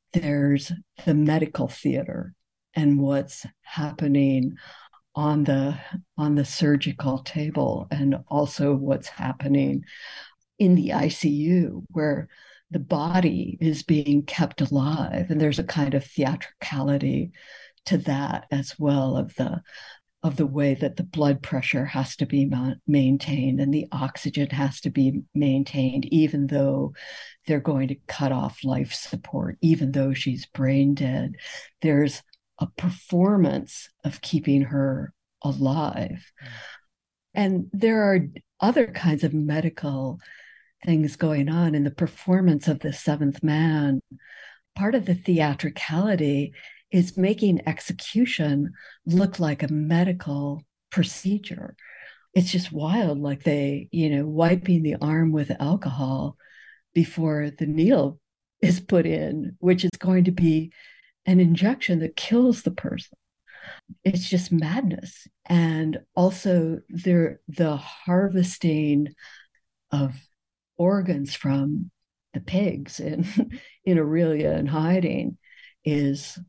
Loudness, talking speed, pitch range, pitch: -24 LUFS, 120 wpm, 140-175 Hz, 155 Hz